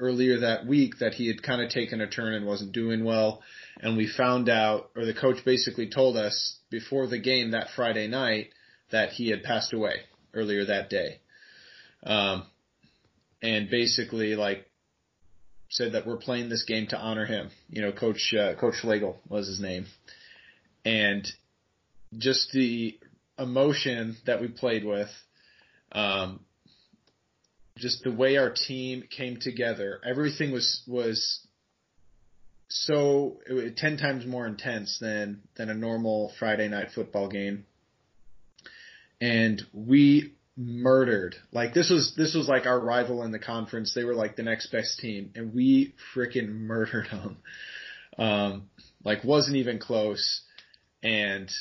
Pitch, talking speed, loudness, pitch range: 115 Hz, 150 wpm, -27 LUFS, 105-125 Hz